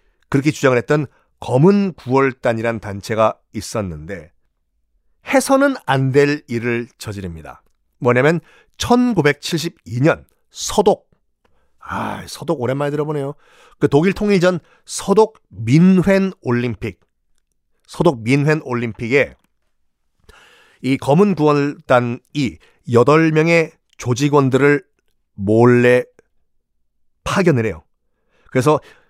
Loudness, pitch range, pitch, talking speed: -17 LUFS, 110-160 Hz, 135 Hz, 200 characters per minute